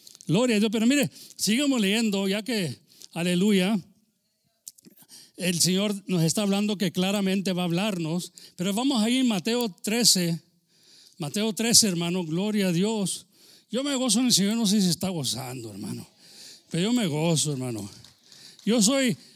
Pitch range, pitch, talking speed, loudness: 175-220 Hz, 195 Hz, 160 wpm, -24 LUFS